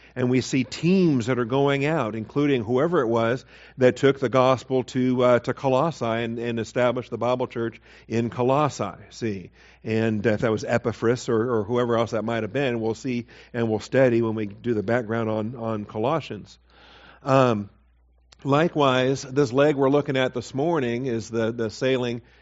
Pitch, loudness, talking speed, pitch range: 120 Hz, -23 LUFS, 180 wpm, 115-130 Hz